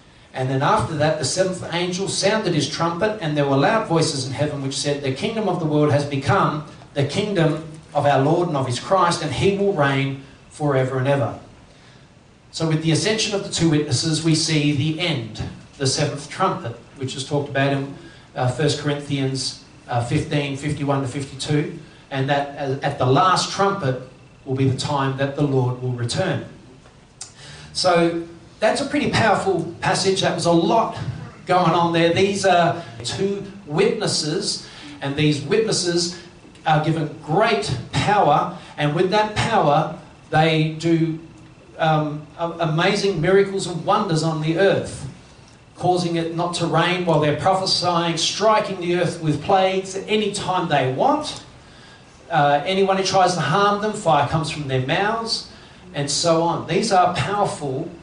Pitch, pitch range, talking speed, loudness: 160 Hz, 145-180 Hz, 160 wpm, -20 LUFS